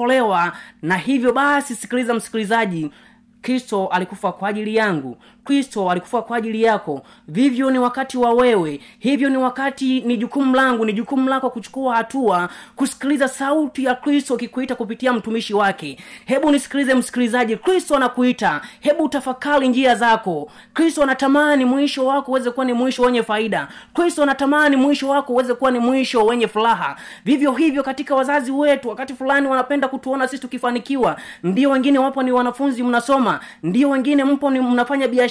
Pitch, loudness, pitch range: 255 Hz, -18 LUFS, 230-275 Hz